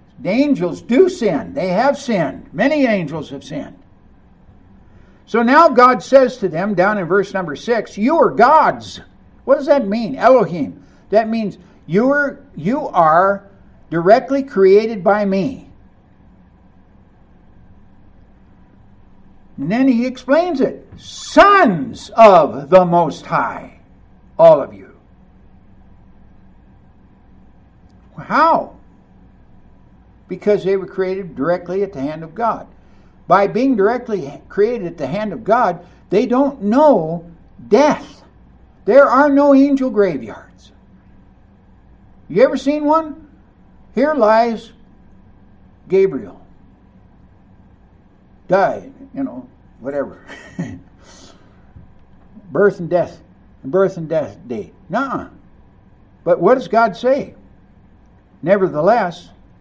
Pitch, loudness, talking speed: 185 Hz, -15 LUFS, 110 wpm